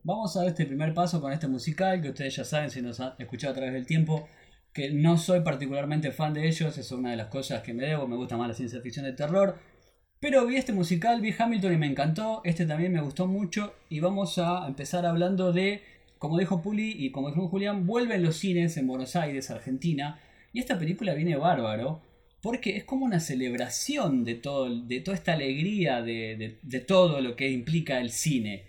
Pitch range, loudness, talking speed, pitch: 135-185 Hz, -29 LUFS, 215 wpm, 160 Hz